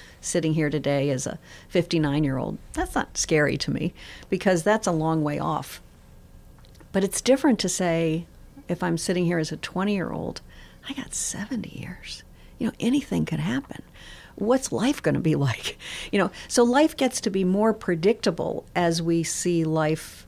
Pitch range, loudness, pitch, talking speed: 160-220 Hz, -25 LUFS, 180 Hz, 180 wpm